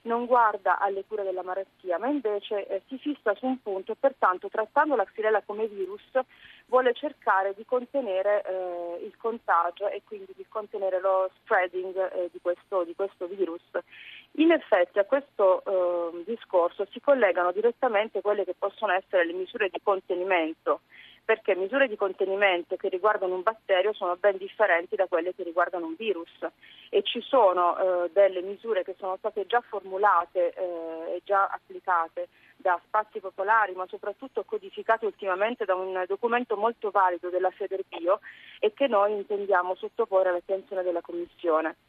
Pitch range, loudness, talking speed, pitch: 185-225 Hz, -27 LUFS, 160 wpm, 200 Hz